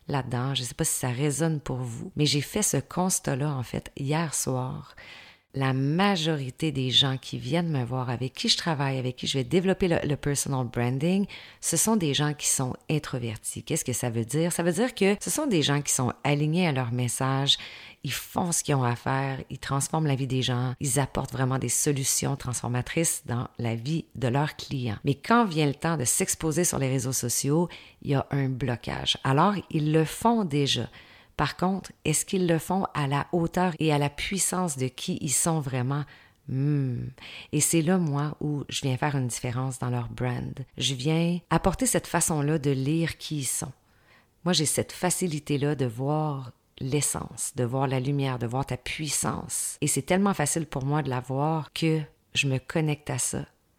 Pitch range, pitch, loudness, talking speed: 130-160 Hz, 140 Hz, -27 LUFS, 205 wpm